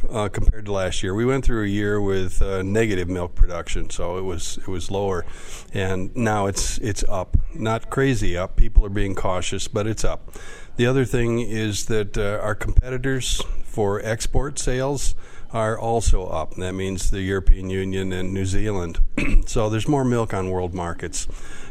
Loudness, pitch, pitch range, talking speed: -24 LUFS, 100 Hz, 95-110 Hz, 180 wpm